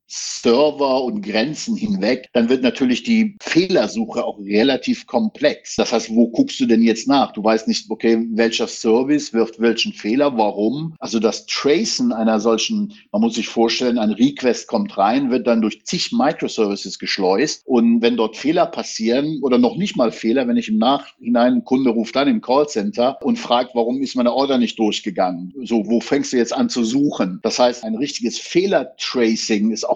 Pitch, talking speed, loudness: 125 Hz, 185 wpm, -18 LUFS